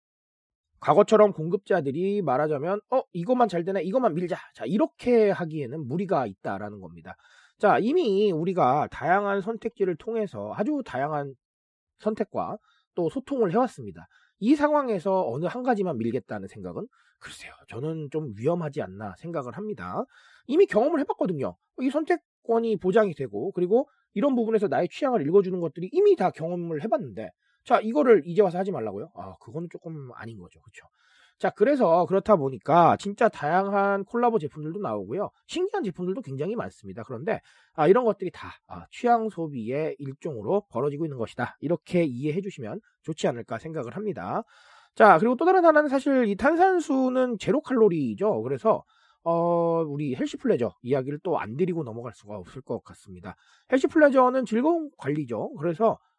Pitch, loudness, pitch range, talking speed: 190 Hz, -25 LUFS, 150-235 Hz, 370 characters per minute